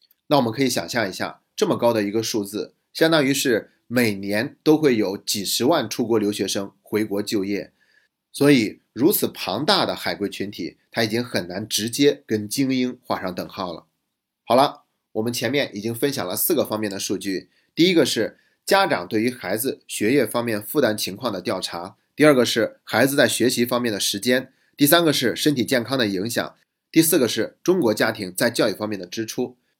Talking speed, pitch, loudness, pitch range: 290 characters per minute, 115 Hz, -21 LUFS, 105-130 Hz